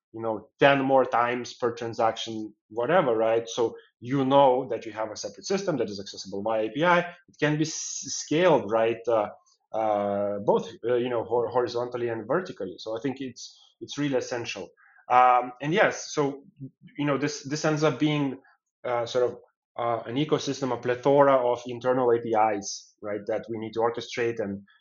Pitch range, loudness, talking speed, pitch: 115-140 Hz, -26 LUFS, 180 wpm, 125 Hz